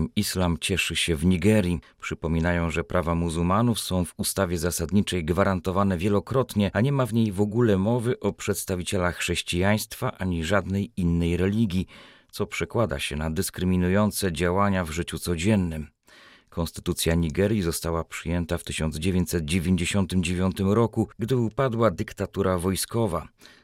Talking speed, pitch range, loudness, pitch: 125 wpm, 85-105 Hz, -25 LUFS, 95 Hz